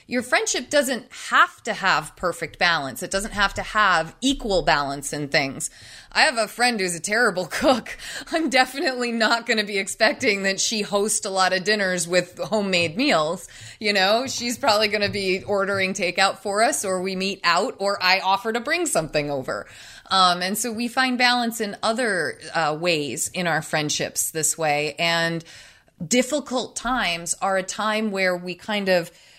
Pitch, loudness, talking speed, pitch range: 200 Hz, -22 LUFS, 180 wpm, 180-235 Hz